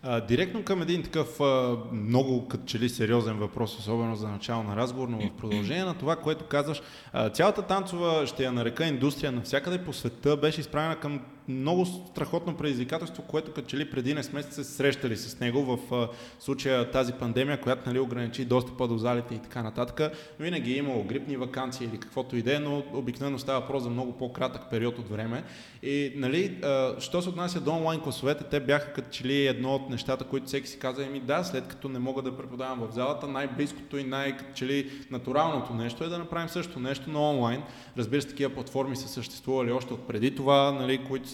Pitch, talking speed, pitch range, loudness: 135 Hz, 200 wpm, 125-145 Hz, -30 LUFS